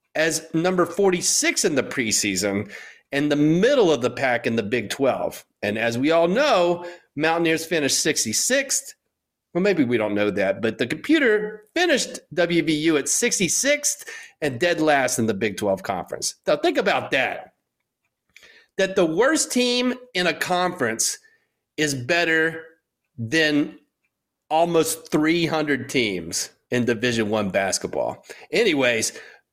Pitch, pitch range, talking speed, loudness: 160 Hz, 135-195 Hz, 135 wpm, -21 LUFS